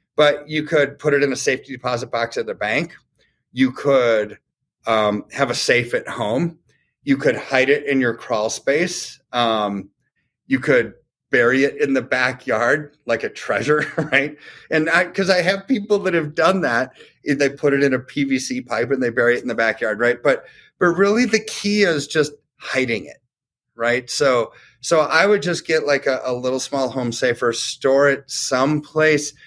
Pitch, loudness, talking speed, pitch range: 140 Hz, -19 LUFS, 185 wpm, 130-160 Hz